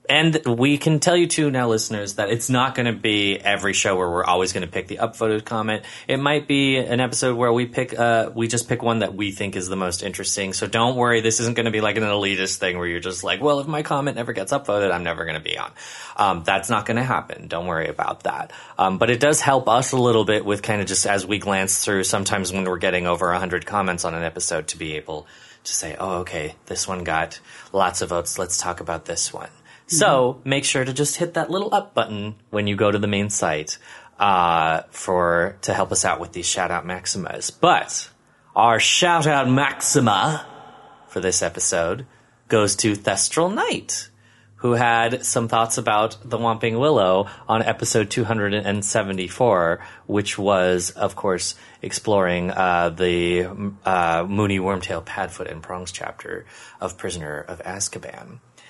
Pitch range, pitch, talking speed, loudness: 95-120 Hz, 105 Hz, 200 wpm, -21 LUFS